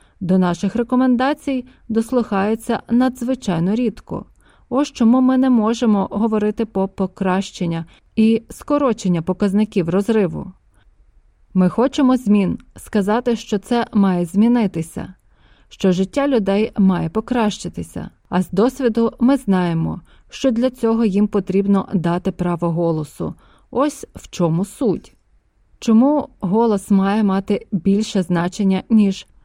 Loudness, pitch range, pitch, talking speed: -18 LUFS, 190-235 Hz, 210 Hz, 110 wpm